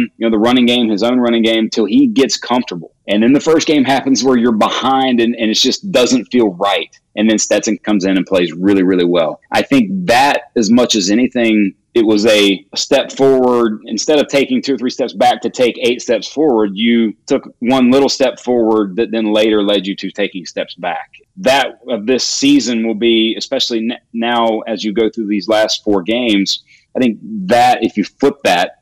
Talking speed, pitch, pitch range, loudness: 215 wpm, 115 Hz, 105-130 Hz, -13 LUFS